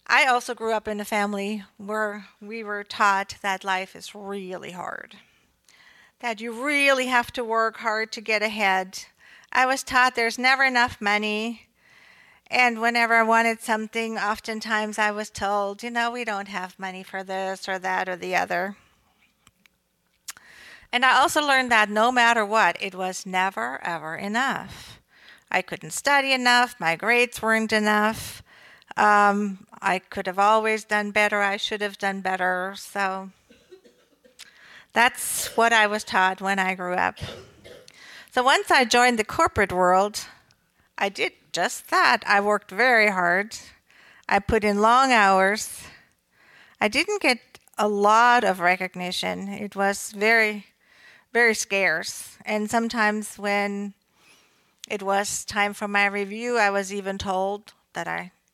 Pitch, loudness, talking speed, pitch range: 210 Hz, -22 LUFS, 150 wpm, 195-230 Hz